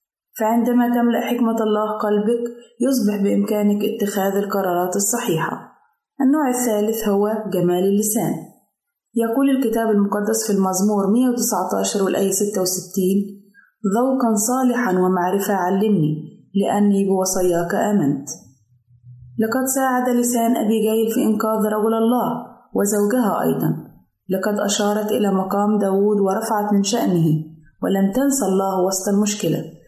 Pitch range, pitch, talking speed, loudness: 190-230 Hz, 205 Hz, 110 wpm, -19 LUFS